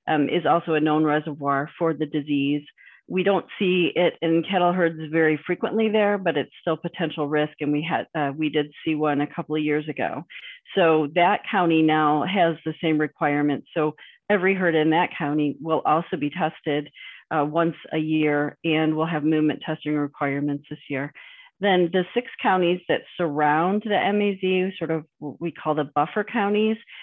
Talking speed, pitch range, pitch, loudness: 185 wpm, 150-180 Hz, 155 Hz, -23 LUFS